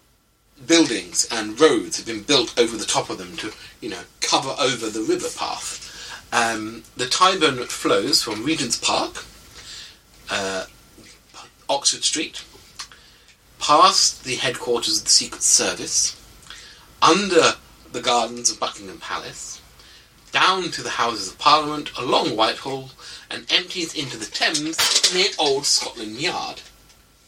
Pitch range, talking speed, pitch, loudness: 115-185 Hz, 130 wpm, 150 Hz, -20 LUFS